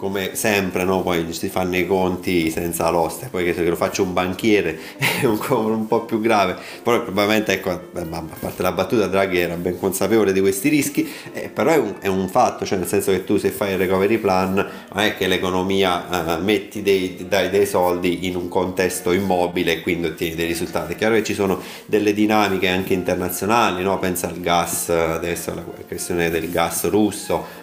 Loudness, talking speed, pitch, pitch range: -20 LUFS, 205 wpm, 95 Hz, 90-100 Hz